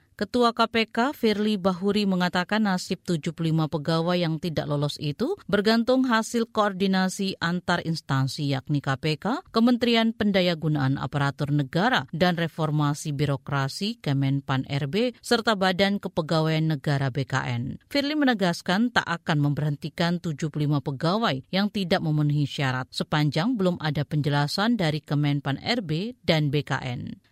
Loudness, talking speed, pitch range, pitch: -25 LUFS, 115 wpm, 145-205 Hz, 170 Hz